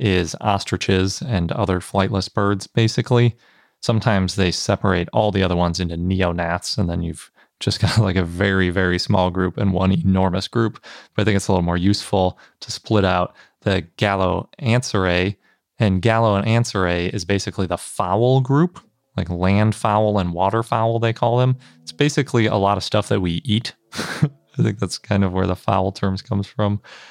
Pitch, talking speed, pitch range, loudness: 100 Hz, 180 wpm, 95-110 Hz, -20 LUFS